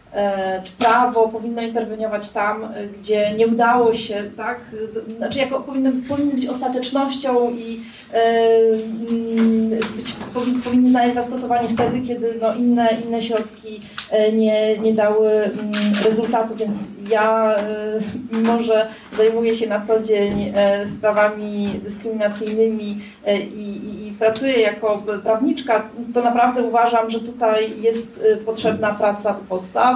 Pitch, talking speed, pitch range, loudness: 220 Hz, 125 wpm, 210-235 Hz, -19 LUFS